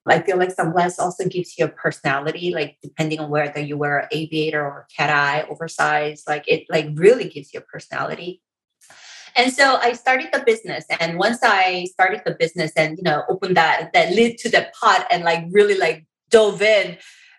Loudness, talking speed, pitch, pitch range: -19 LUFS, 195 wpm, 170 Hz, 155-215 Hz